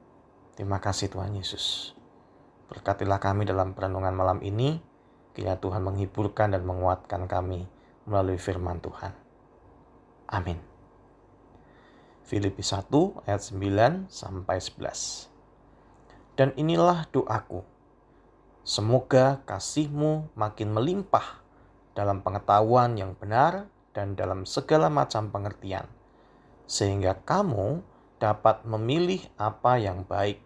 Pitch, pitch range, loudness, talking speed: 100 Hz, 95-120 Hz, -27 LUFS, 95 wpm